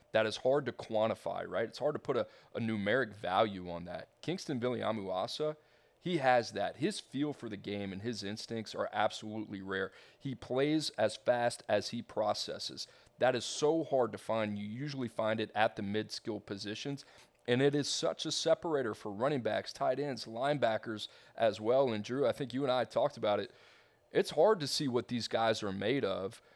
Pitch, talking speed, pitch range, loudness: 115 Hz, 200 wpm, 105-140 Hz, -34 LUFS